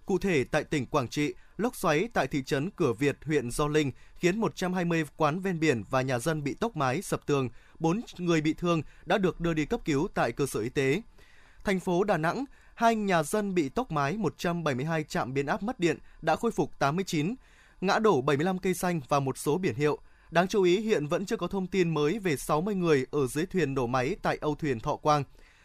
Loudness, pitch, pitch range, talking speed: -29 LUFS, 160 Hz, 145-185 Hz, 225 wpm